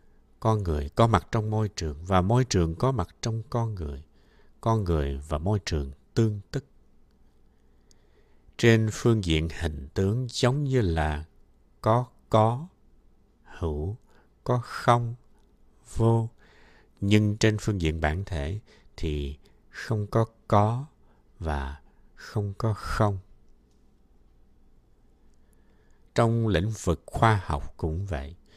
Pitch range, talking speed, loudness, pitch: 75-115 Hz, 120 wpm, -27 LUFS, 100 Hz